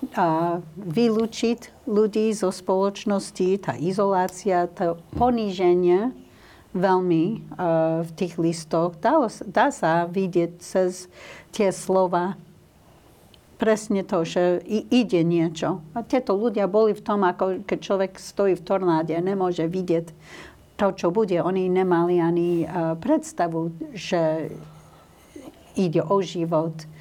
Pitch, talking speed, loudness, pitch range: 185 Hz, 120 wpm, -23 LUFS, 170-200 Hz